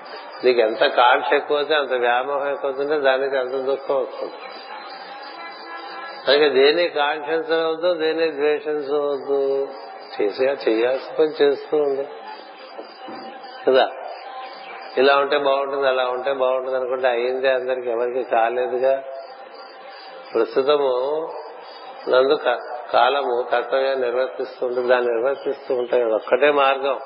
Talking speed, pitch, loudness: 100 wpm, 140 Hz, -20 LUFS